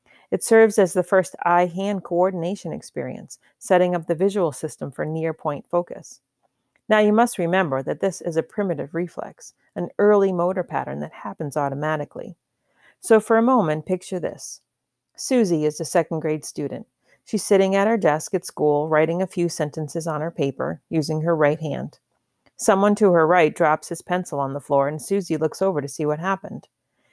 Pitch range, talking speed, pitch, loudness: 155-195 Hz, 185 wpm, 170 Hz, -22 LUFS